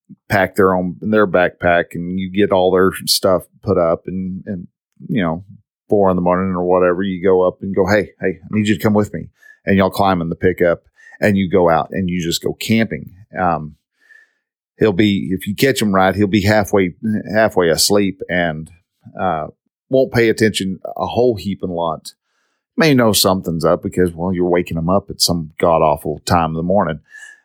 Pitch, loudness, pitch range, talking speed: 95 Hz, -16 LUFS, 90-105 Hz, 200 wpm